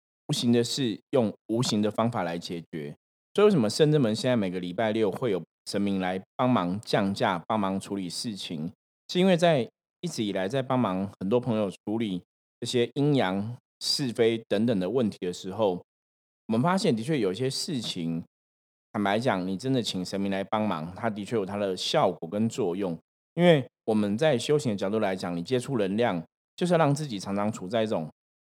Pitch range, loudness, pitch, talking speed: 95-125 Hz, -27 LUFS, 110 Hz, 290 characters per minute